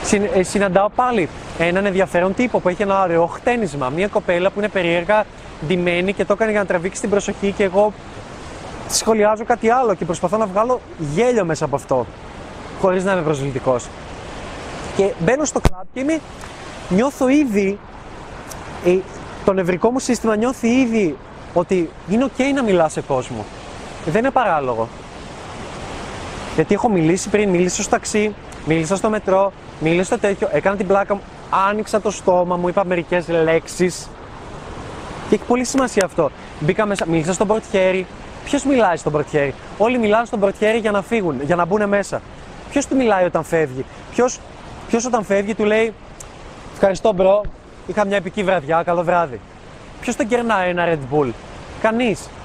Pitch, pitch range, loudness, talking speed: 195 Hz, 170-215 Hz, -18 LUFS, 160 wpm